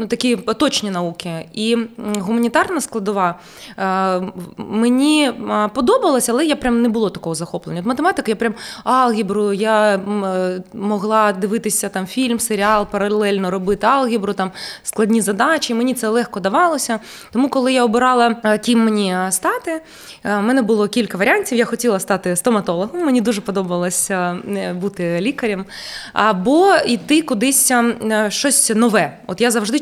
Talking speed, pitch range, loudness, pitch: 130 wpm, 200-245 Hz, -17 LUFS, 220 Hz